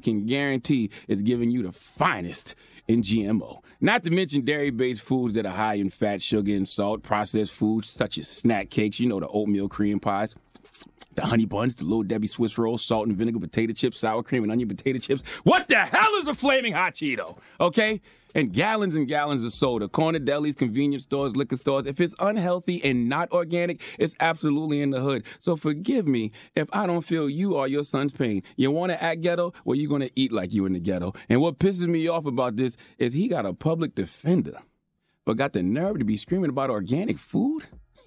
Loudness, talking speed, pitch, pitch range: -25 LUFS, 215 wpm, 135 Hz, 110-165 Hz